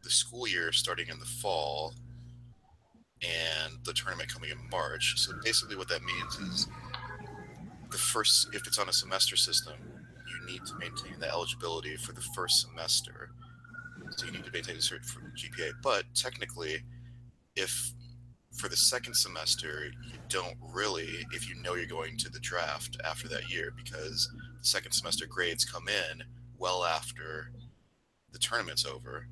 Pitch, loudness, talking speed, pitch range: 120 Hz, -31 LUFS, 160 wpm, 90-120 Hz